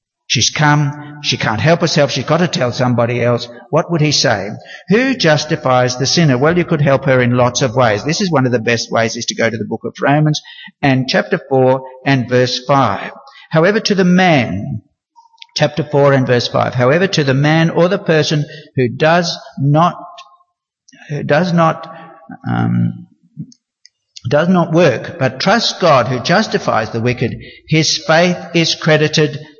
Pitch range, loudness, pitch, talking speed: 125-170 Hz, -14 LUFS, 150 Hz, 175 wpm